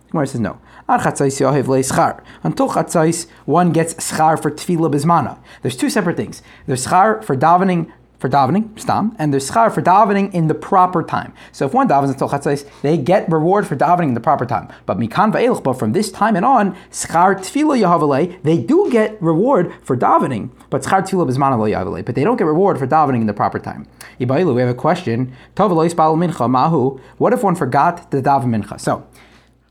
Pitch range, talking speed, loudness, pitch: 140-175 Hz, 165 wpm, -16 LUFS, 160 Hz